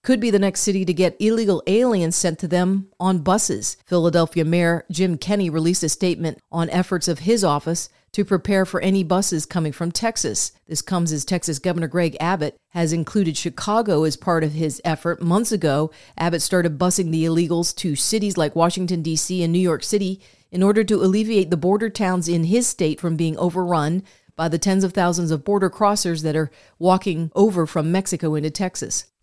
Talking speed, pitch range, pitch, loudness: 195 wpm, 165-190 Hz, 175 Hz, -20 LUFS